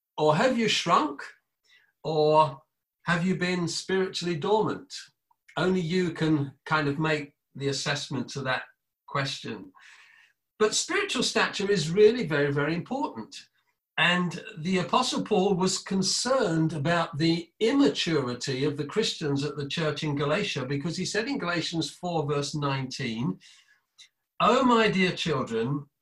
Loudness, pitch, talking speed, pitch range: -26 LUFS, 165 Hz, 135 wpm, 145-195 Hz